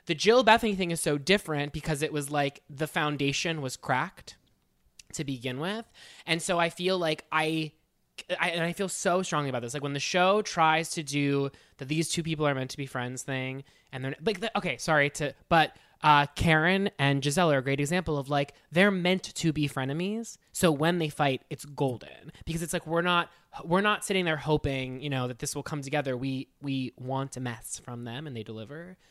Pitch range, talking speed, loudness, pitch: 140-170 Hz, 215 wpm, -28 LUFS, 150 Hz